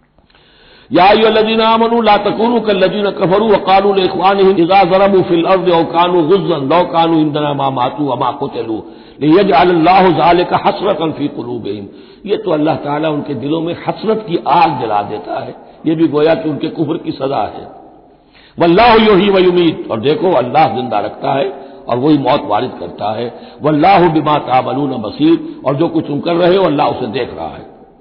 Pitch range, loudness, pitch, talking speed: 150-195 Hz, -12 LUFS, 170 Hz, 145 wpm